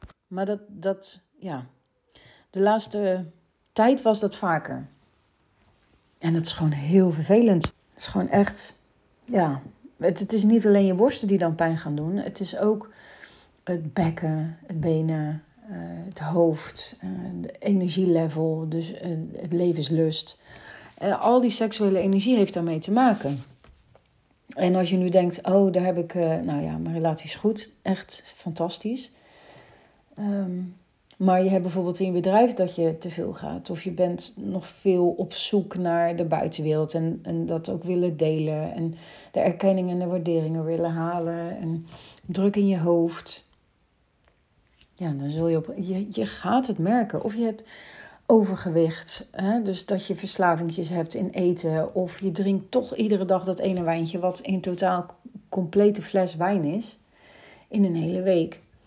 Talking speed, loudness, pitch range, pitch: 160 wpm, -25 LUFS, 165-195 Hz, 180 Hz